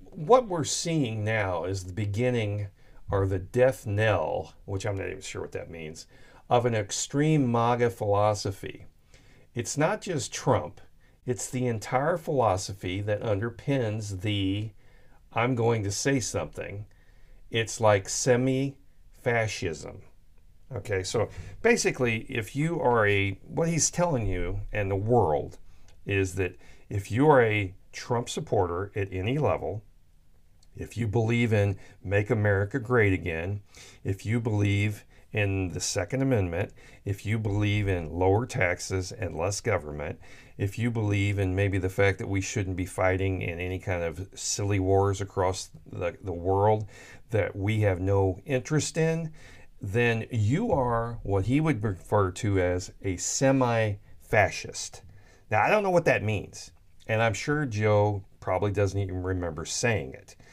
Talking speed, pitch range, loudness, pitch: 150 wpm, 95-120 Hz, -27 LUFS, 105 Hz